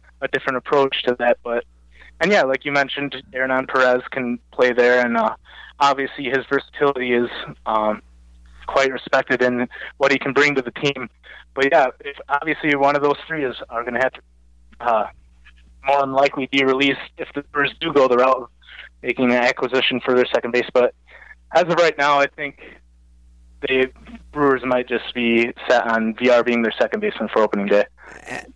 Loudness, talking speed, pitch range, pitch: -19 LUFS, 190 wpm, 120-140 Hz, 130 Hz